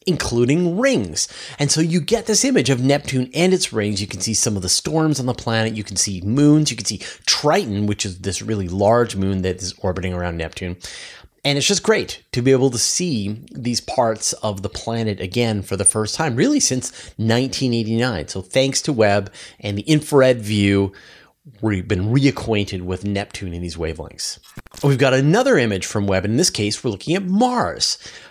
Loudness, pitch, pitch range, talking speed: -19 LUFS, 110 Hz, 100-140 Hz, 200 wpm